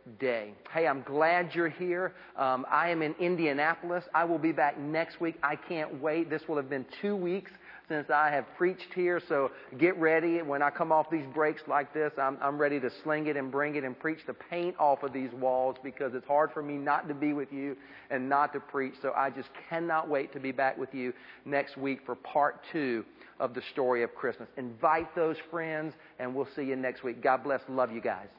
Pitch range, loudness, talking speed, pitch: 135-165 Hz, -31 LUFS, 225 wpm, 150 Hz